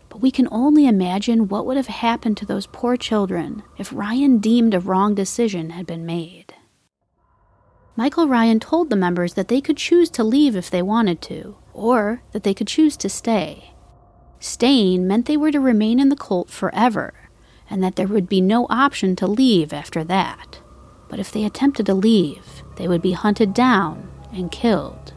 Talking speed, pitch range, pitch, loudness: 185 wpm, 185-245 Hz, 215 Hz, -19 LUFS